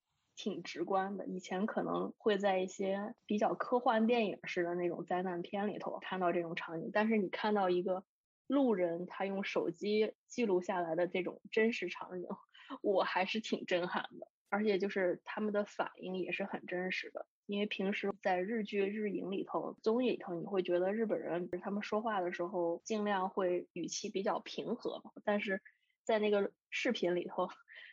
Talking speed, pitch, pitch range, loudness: 270 characters per minute, 200 Hz, 180-215 Hz, -36 LUFS